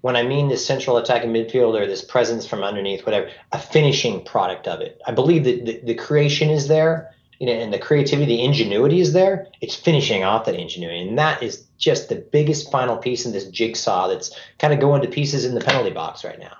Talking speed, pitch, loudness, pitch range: 230 wpm, 135 Hz, -20 LUFS, 120-155 Hz